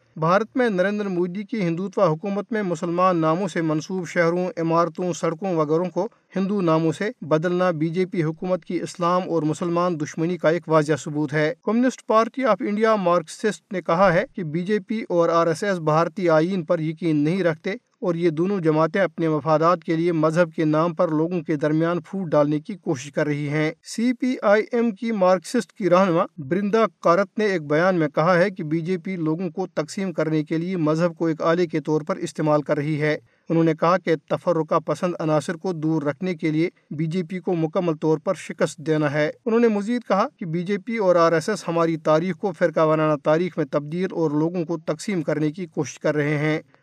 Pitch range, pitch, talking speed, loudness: 160-190 Hz, 170 Hz, 215 wpm, -22 LUFS